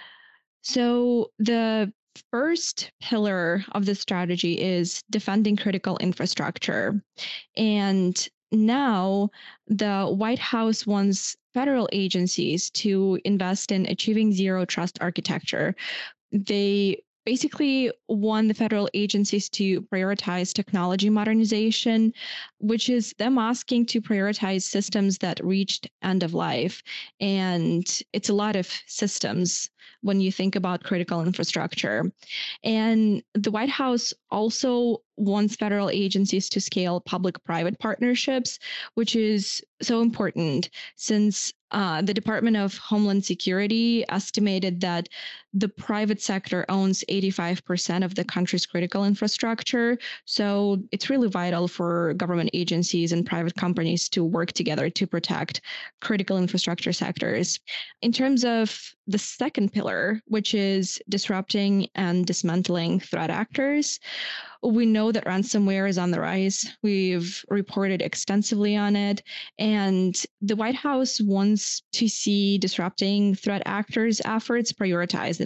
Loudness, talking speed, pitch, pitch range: -25 LUFS, 120 wpm, 200 Hz, 185-220 Hz